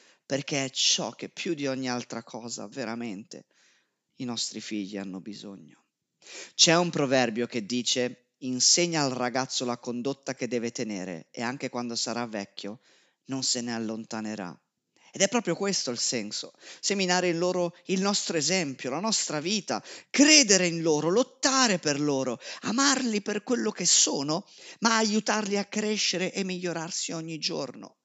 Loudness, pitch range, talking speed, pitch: -26 LUFS, 120-190 Hz, 150 wpm, 145 Hz